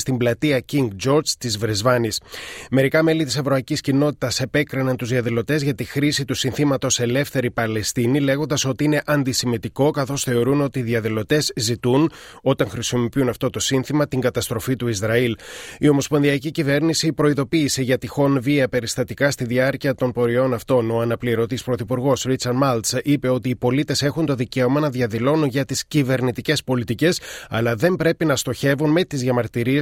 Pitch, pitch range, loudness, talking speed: 130 Hz, 125-145 Hz, -20 LUFS, 160 wpm